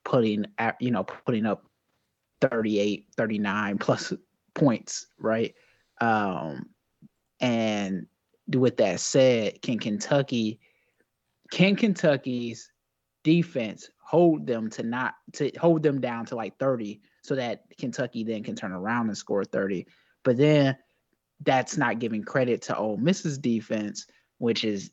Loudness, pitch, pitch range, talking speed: -27 LUFS, 115 Hz, 105-135 Hz, 130 wpm